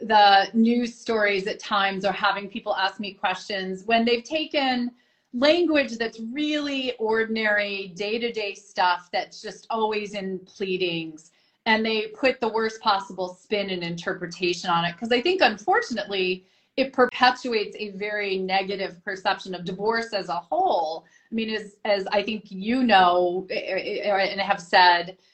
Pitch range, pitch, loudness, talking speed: 190-230 Hz, 205 Hz, -24 LUFS, 145 wpm